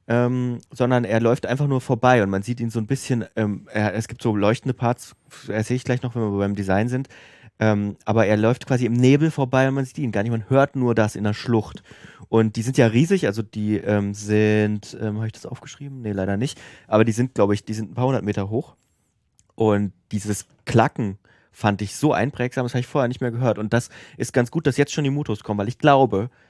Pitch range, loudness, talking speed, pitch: 105-130 Hz, -22 LUFS, 245 wpm, 115 Hz